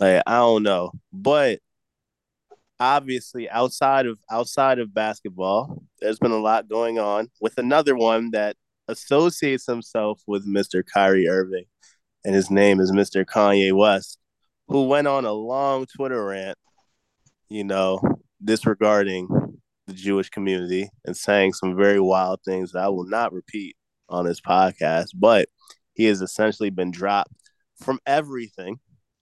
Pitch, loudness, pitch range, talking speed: 105 Hz, -21 LUFS, 95-120 Hz, 140 wpm